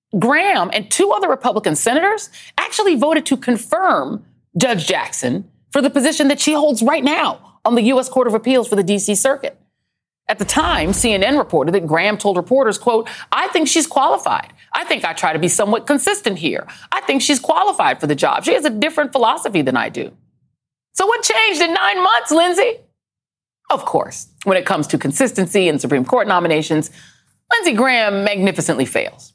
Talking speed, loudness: 185 wpm, -16 LUFS